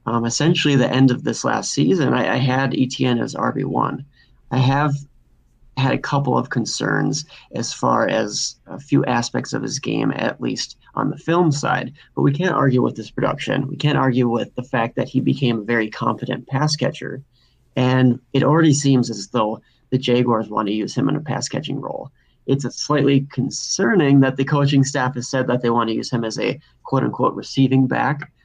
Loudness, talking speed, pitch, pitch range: -19 LUFS, 200 wpm, 130 Hz, 125-140 Hz